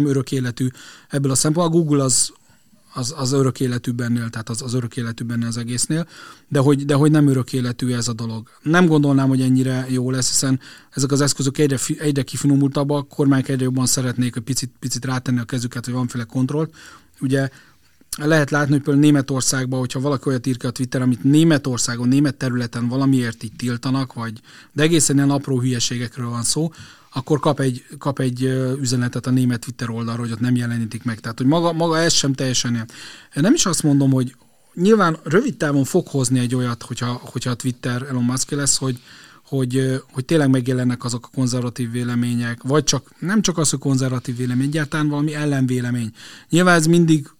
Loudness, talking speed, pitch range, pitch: -19 LUFS, 190 wpm, 125-145 Hz, 130 Hz